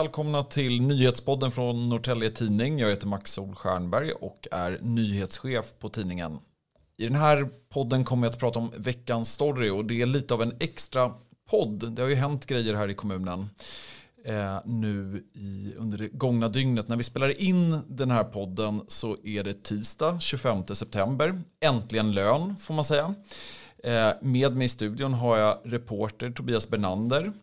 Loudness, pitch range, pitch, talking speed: -27 LUFS, 105-135 Hz, 120 Hz, 165 wpm